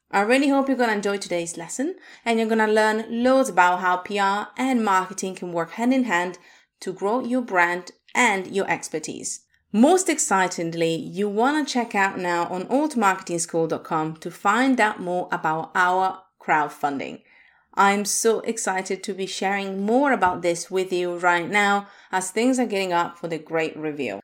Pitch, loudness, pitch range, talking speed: 195 Hz, -22 LUFS, 175-230 Hz, 175 wpm